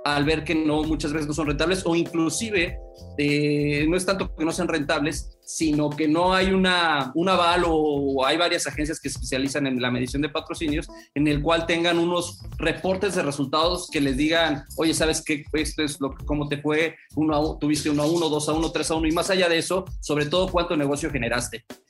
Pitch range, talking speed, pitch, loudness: 145-165 Hz, 215 wpm, 155 Hz, -23 LUFS